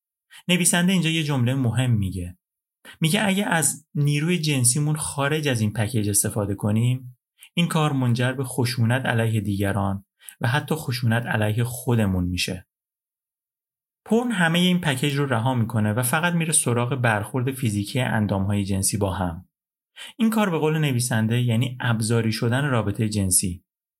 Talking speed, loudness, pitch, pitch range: 145 wpm, -22 LUFS, 125 Hz, 110-150 Hz